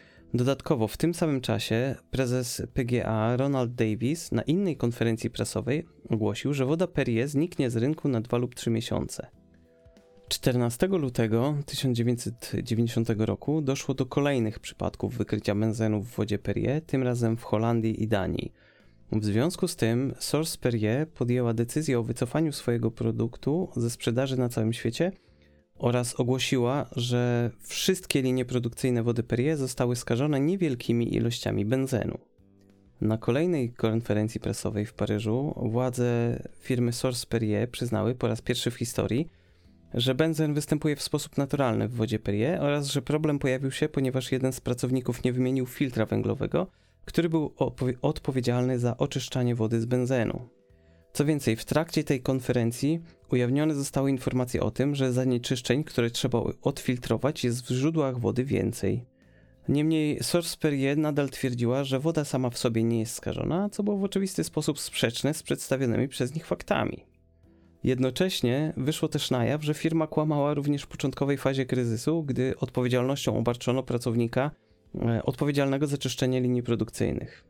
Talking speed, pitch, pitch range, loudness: 145 wpm, 125 Hz, 115-140 Hz, -28 LUFS